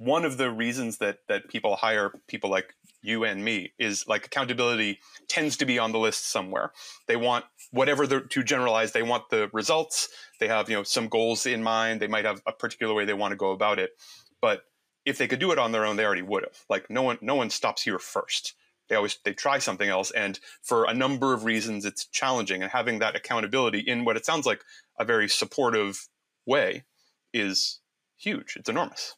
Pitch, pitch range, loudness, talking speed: 115 Hz, 110-135 Hz, -27 LUFS, 215 wpm